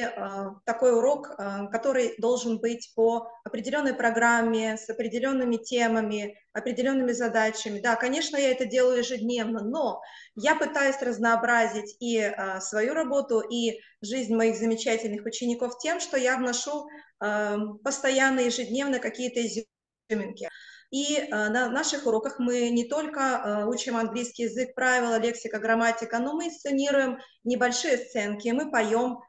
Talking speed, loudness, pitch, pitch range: 120 wpm, -27 LUFS, 240 Hz, 225-260 Hz